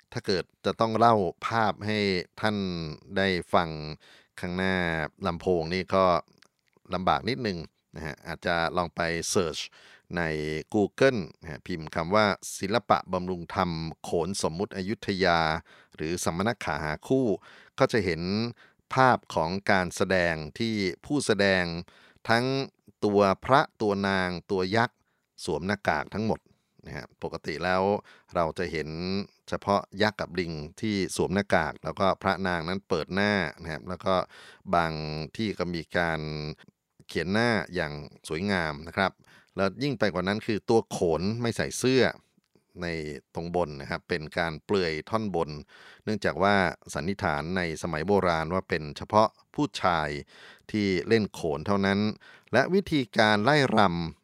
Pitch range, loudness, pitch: 85-105 Hz, -28 LUFS, 95 Hz